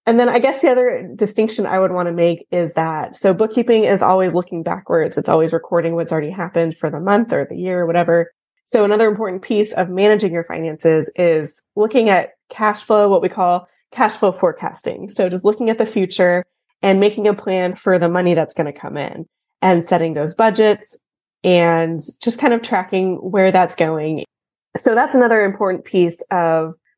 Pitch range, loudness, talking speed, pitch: 170-215 Hz, -16 LUFS, 200 wpm, 185 Hz